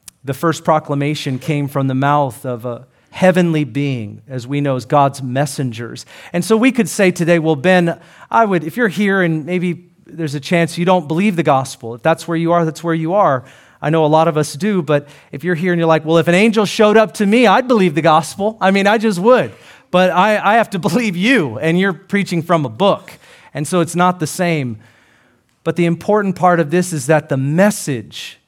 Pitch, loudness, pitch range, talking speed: 170 Hz, -15 LUFS, 145-190 Hz, 230 wpm